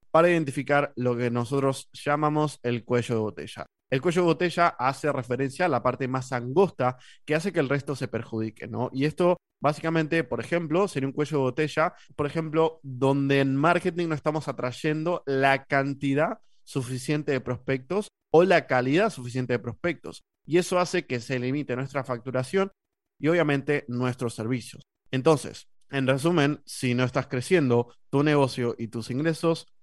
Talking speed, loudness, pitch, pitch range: 165 wpm, -26 LUFS, 140 Hz, 125-160 Hz